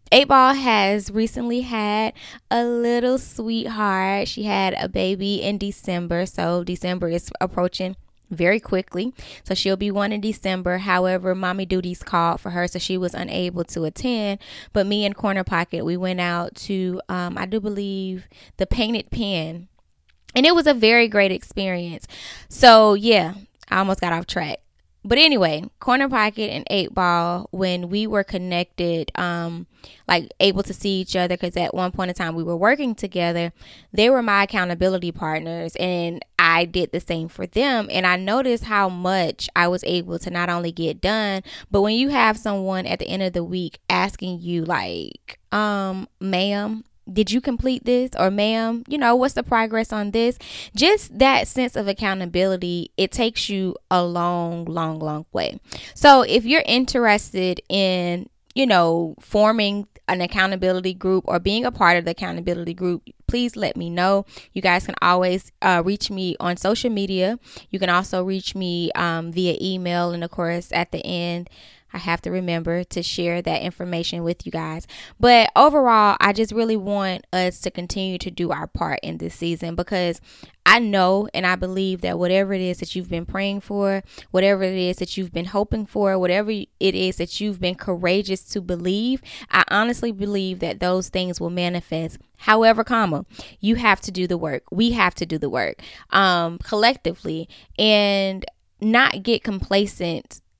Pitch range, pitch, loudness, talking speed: 175-210 Hz, 190 Hz, -21 LUFS, 175 wpm